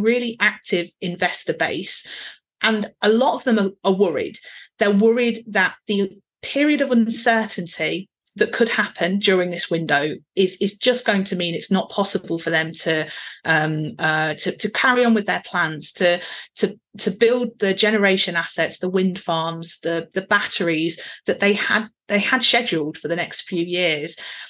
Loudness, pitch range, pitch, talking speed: -20 LUFS, 170-215 Hz, 195 Hz, 170 wpm